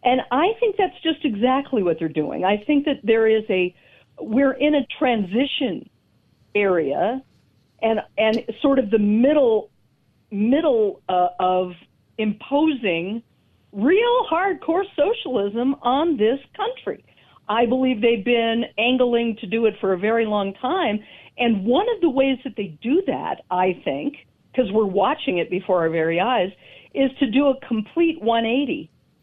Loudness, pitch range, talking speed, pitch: -21 LUFS, 210-285 Hz, 150 wpm, 245 Hz